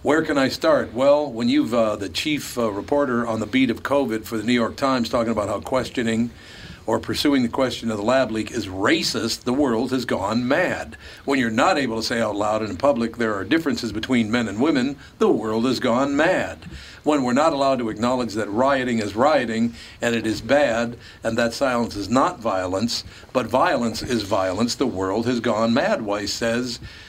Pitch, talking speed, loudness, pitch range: 115 Hz, 215 wpm, -22 LUFS, 110-125 Hz